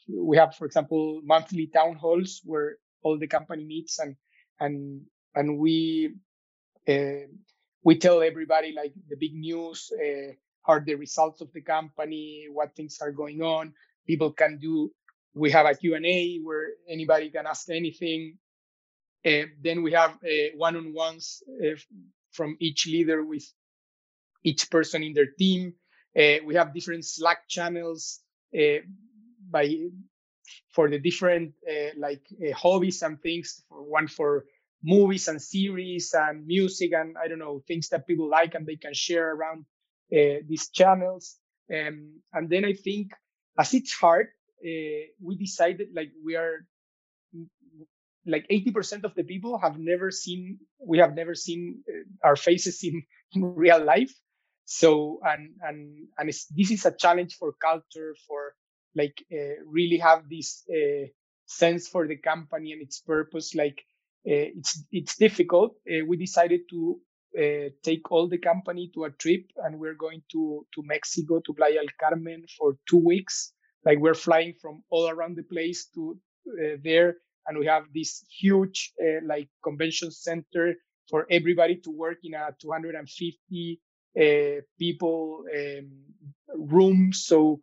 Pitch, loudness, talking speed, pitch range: 165 Hz, -26 LUFS, 155 wpm, 155-175 Hz